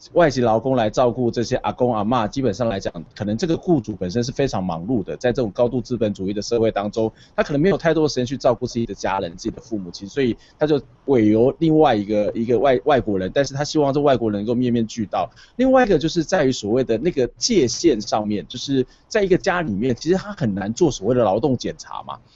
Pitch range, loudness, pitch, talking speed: 110-145 Hz, -20 LUFS, 125 Hz, 375 characters per minute